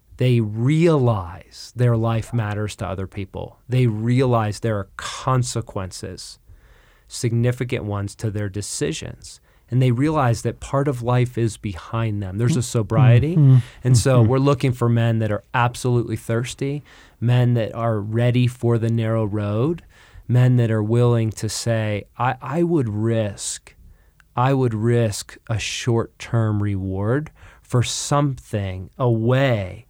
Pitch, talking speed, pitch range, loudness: 115 Hz, 135 wpm, 105-125 Hz, -21 LUFS